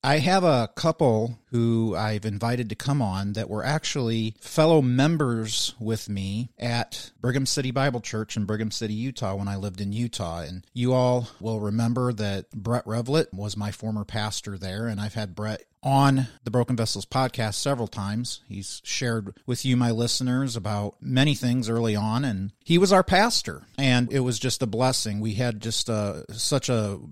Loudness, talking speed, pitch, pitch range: -25 LUFS, 185 wpm, 115 Hz, 105-130 Hz